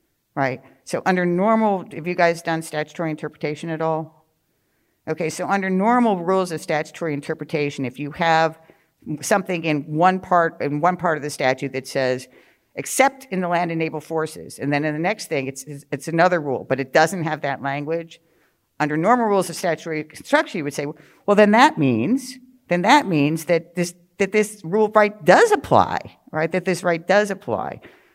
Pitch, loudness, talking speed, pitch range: 165 Hz, -21 LUFS, 190 wpm, 150-190 Hz